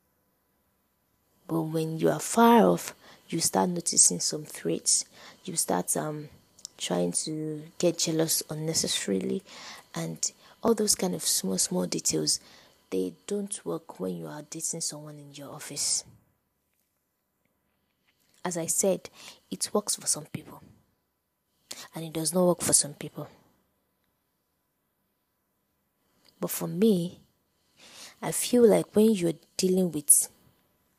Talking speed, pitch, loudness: 125 wpm, 150 Hz, -26 LUFS